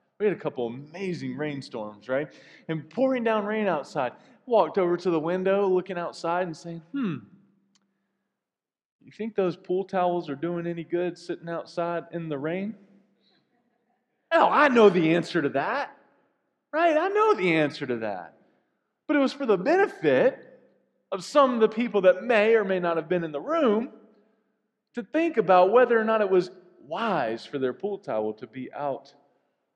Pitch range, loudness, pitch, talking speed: 170-225 Hz, -25 LUFS, 190 Hz, 175 wpm